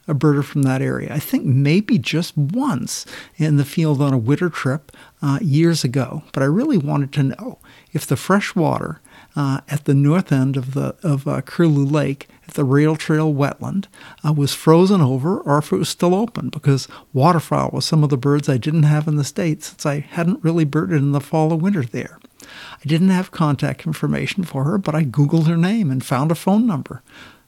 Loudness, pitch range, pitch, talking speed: -19 LUFS, 140-165 Hz, 150 Hz, 210 wpm